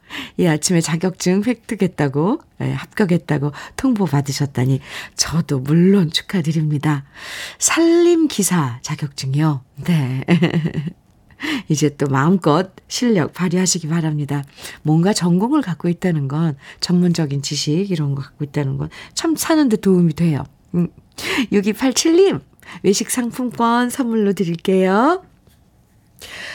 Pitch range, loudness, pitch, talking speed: 150-210 Hz, -18 LUFS, 175 Hz, 245 characters per minute